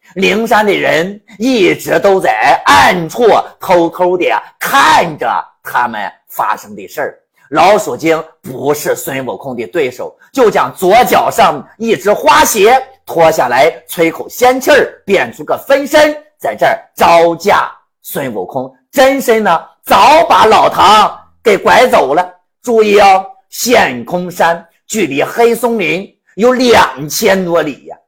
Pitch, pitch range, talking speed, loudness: 205 Hz, 170-260 Hz, 200 characters per minute, -10 LUFS